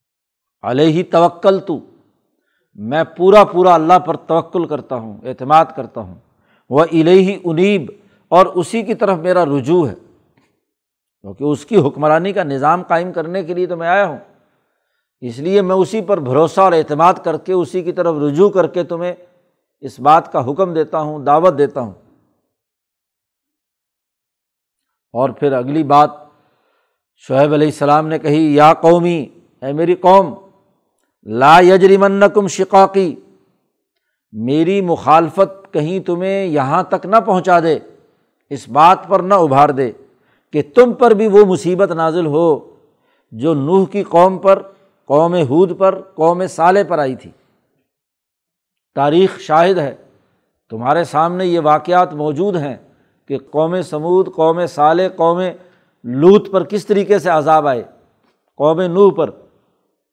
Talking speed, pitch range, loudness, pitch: 145 wpm, 150-190 Hz, -13 LUFS, 175 Hz